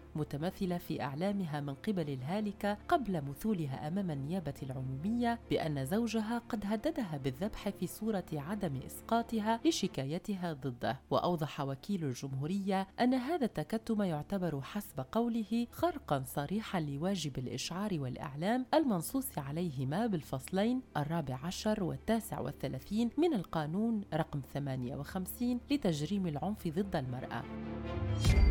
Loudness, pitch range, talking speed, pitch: -36 LUFS, 145-220 Hz, 110 wpm, 175 Hz